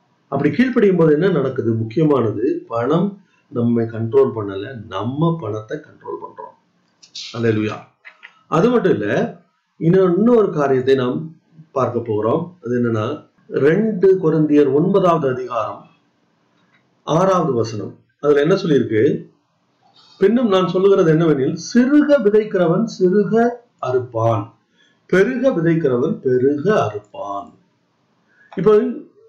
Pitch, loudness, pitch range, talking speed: 160 Hz, -17 LUFS, 120-200 Hz, 80 wpm